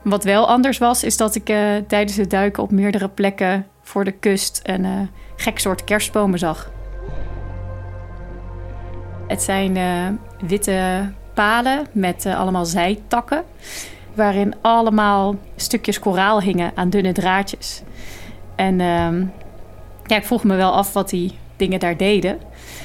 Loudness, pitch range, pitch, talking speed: -19 LUFS, 180-210 Hz, 195 Hz, 140 wpm